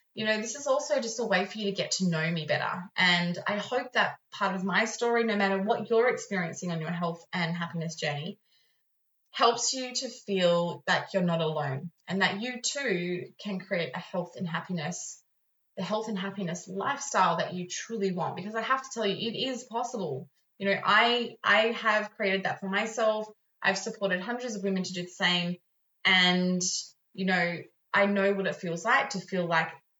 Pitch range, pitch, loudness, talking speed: 180-225 Hz, 195 Hz, -29 LUFS, 200 wpm